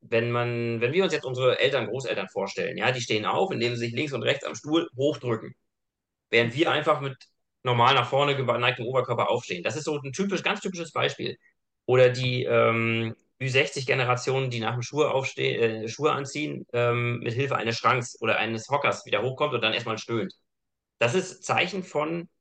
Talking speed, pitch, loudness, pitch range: 185 wpm, 125 Hz, -26 LUFS, 120-150 Hz